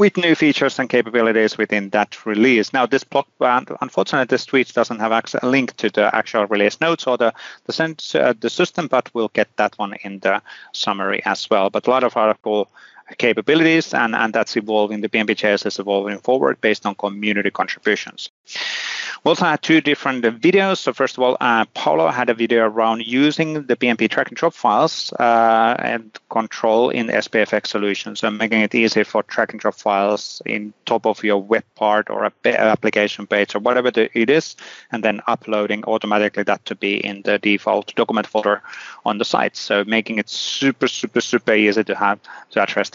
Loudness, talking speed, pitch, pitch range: -18 LUFS, 195 wpm, 115 Hz, 105-125 Hz